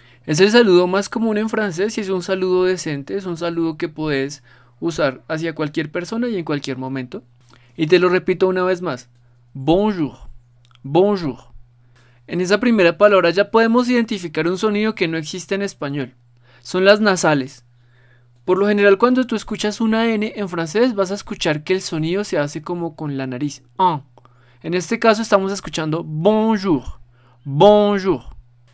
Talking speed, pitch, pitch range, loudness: 170 wpm, 170 Hz, 135-200 Hz, -18 LUFS